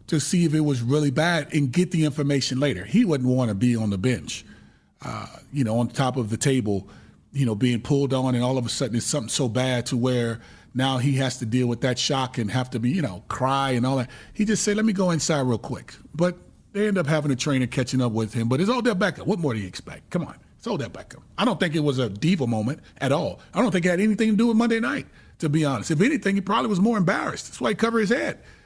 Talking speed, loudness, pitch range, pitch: 285 wpm, -23 LUFS, 125-180 Hz, 140 Hz